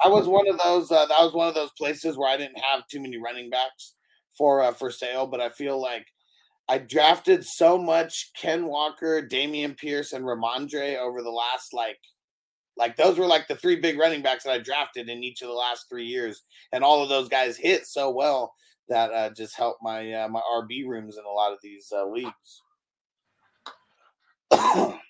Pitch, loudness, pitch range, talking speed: 135 Hz, -24 LUFS, 120-160 Hz, 205 wpm